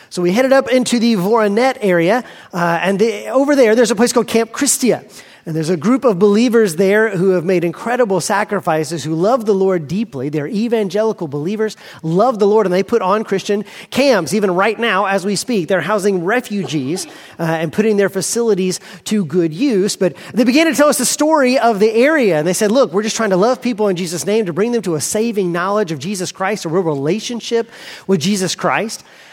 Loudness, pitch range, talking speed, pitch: -15 LUFS, 185-230 Hz, 215 wpm, 205 Hz